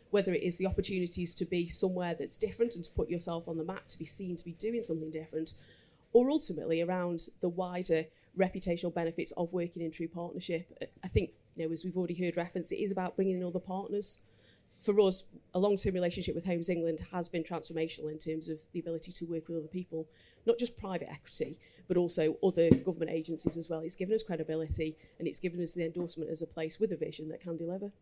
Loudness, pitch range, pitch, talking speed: -33 LUFS, 160-185 Hz, 170 Hz, 225 wpm